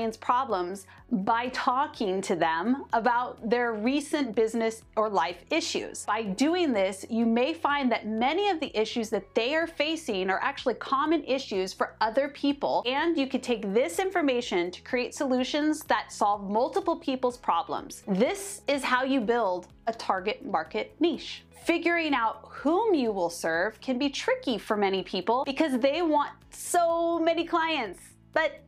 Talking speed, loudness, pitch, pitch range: 160 wpm, -28 LUFS, 255 Hz, 220-305 Hz